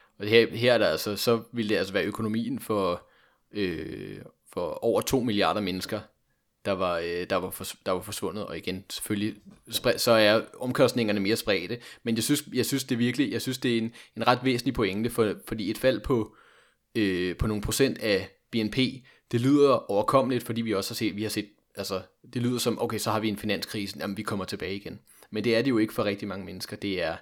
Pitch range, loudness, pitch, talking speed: 105-120 Hz, -27 LUFS, 110 Hz, 225 wpm